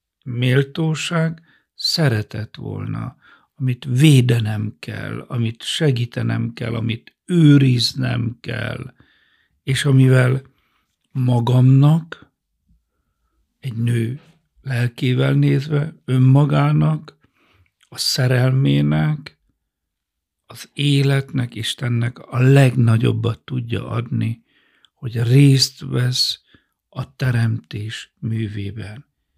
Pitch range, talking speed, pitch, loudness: 115-140 Hz, 70 wpm, 125 Hz, -18 LUFS